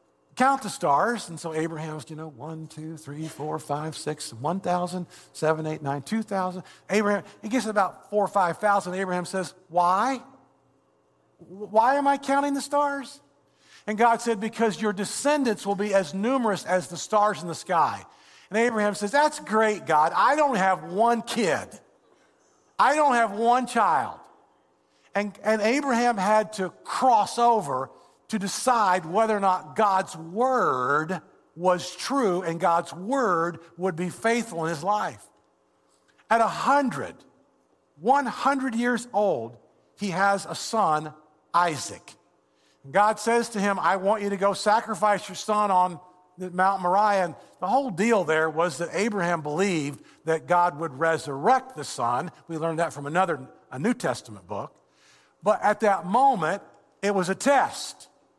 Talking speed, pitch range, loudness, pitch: 145 wpm, 165-225 Hz, -25 LUFS, 195 Hz